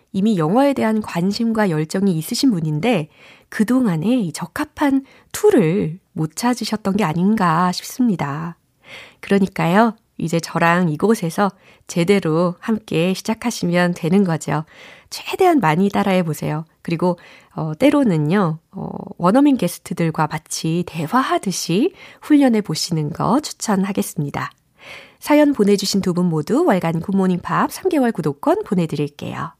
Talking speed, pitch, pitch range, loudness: 290 characters per minute, 190 Hz, 165-225 Hz, -18 LUFS